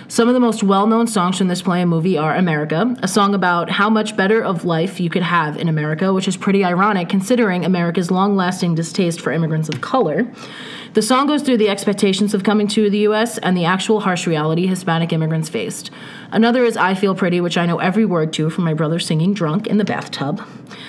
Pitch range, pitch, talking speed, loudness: 170-210 Hz, 190 Hz, 225 wpm, -17 LUFS